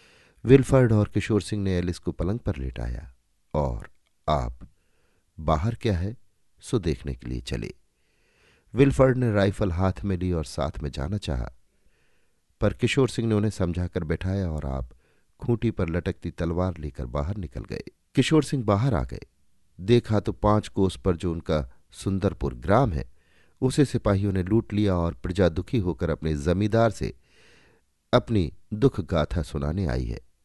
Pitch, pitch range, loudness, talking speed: 95 Hz, 80-105 Hz, -26 LUFS, 160 wpm